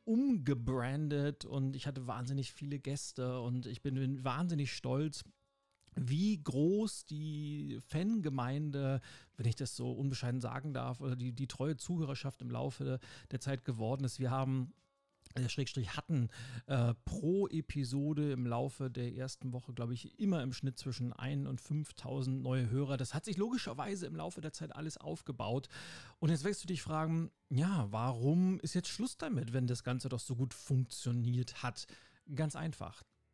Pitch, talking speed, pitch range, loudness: 135 Hz, 160 wpm, 125-155 Hz, -38 LUFS